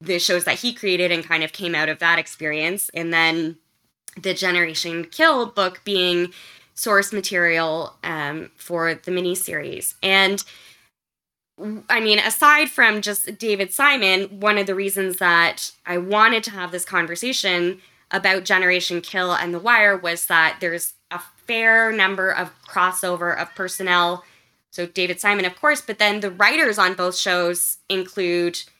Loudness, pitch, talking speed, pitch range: -19 LUFS, 180 Hz, 155 wpm, 175-200 Hz